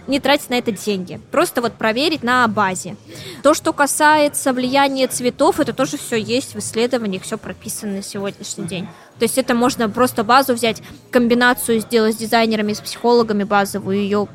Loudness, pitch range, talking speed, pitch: -17 LUFS, 210-260 Hz, 170 wpm, 235 Hz